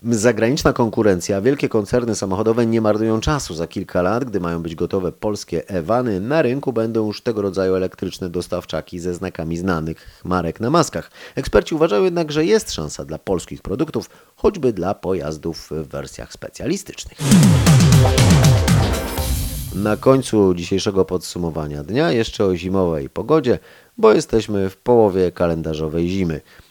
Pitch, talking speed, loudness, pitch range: 95 Hz, 135 wpm, -19 LUFS, 85-115 Hz